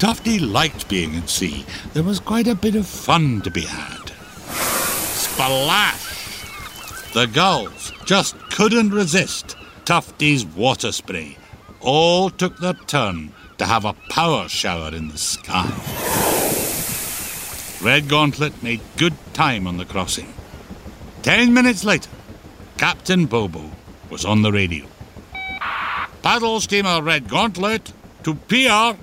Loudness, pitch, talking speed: -19 LUFS, 145 Hz, 120 wpm